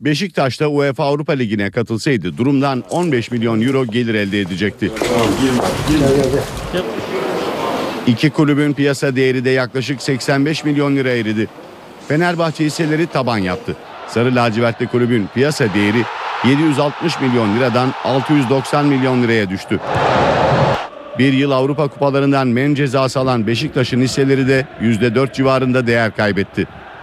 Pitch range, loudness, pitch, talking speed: 120-145 Hz, -16 LUFS, 130 Hz, 120 wpm